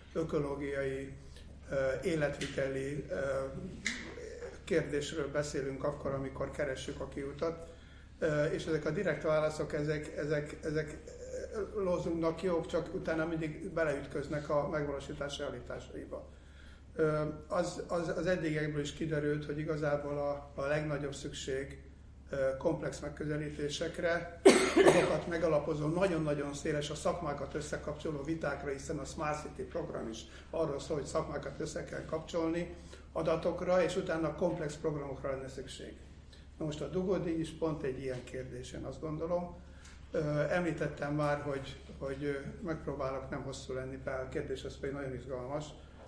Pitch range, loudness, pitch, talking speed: 135-160 Hz, -36 LUFS, 150 Hz, 120 wpm